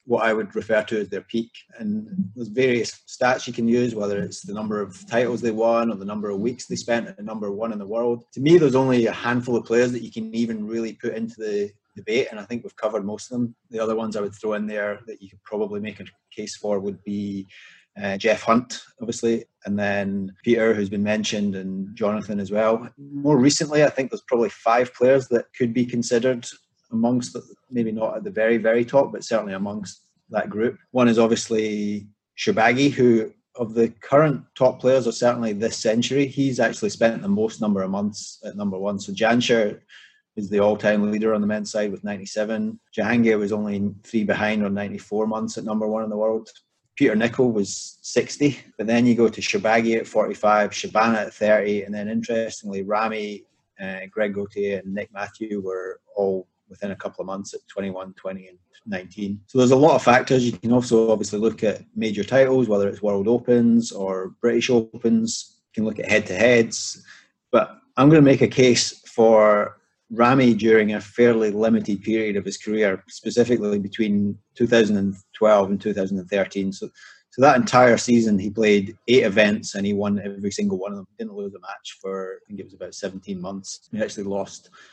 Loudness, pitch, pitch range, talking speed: -22 LUFS, 110 Hz, 105-120 Hz, 205 wpm